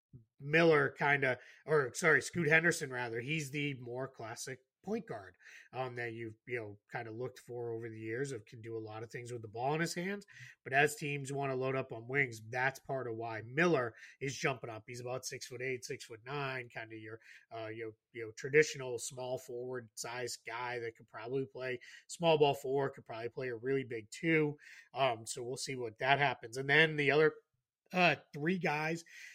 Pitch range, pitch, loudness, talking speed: 120-145 Hz, 130 Hz, -35 LUFS, 210 wpm